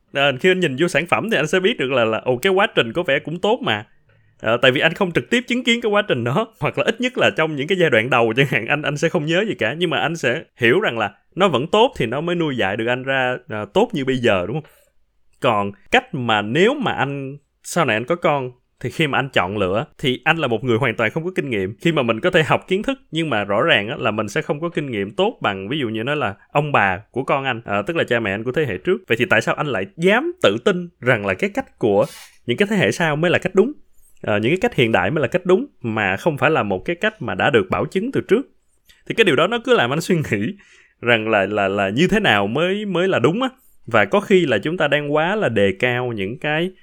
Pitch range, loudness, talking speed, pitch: 115-185 Hz, -19 LUFS, 295 wpm, 150 Hz